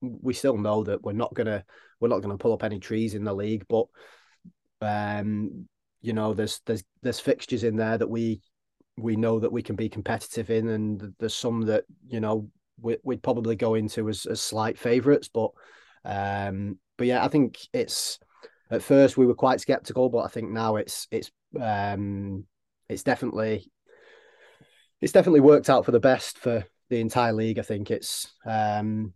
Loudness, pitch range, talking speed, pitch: -26 LUFS, 105-120 Hz, 185 wpm, 110 Hz